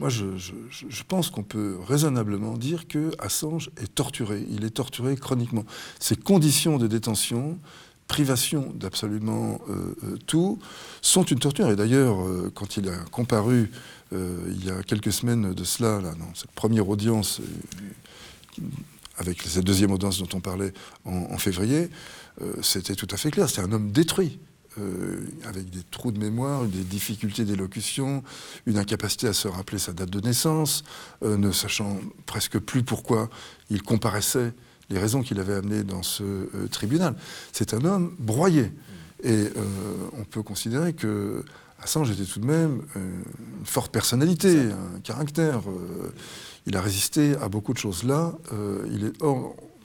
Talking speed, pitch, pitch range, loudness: 160 wpm, 110 Hz, 100-135 Hz, -26 LUFS